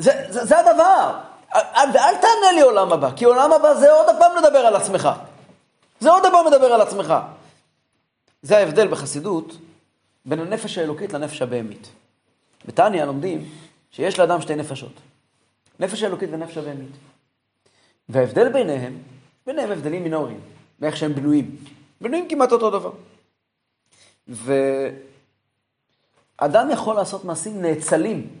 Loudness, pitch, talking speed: -18 LUFS, 165 Hz, 125 wpm